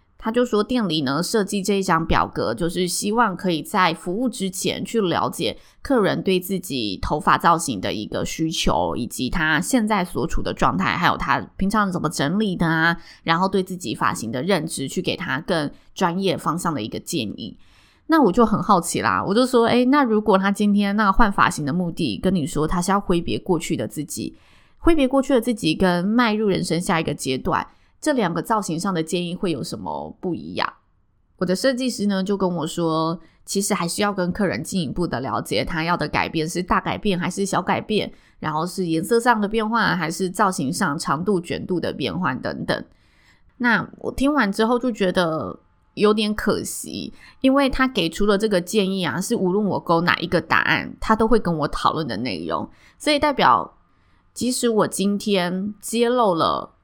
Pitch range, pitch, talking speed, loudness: 165-215 Hz, 190 Hz, 285 characters per minute, -21 LUFS